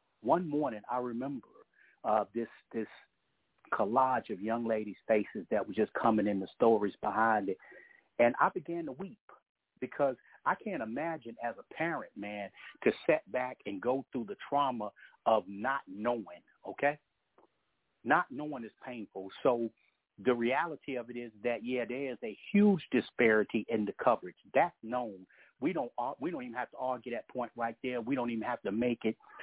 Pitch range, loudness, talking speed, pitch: 110-125 Hz, -34 LUFS, 175 wpm, 120 Hz